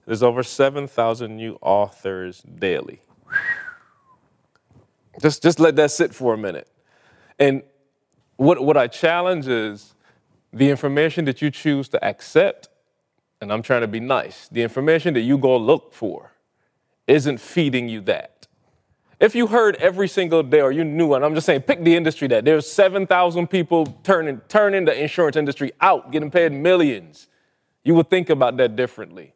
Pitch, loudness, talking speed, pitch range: 155 Hz, -19 LUFS, 160 wpm, 135-180 Hz